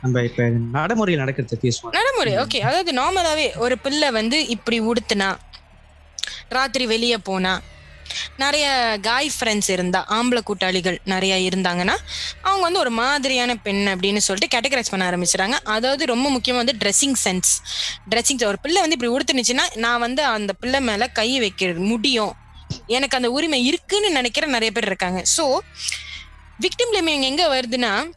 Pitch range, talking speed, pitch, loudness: 190-275 Hz, 90 wpm, 235 Hz, -20 LUFS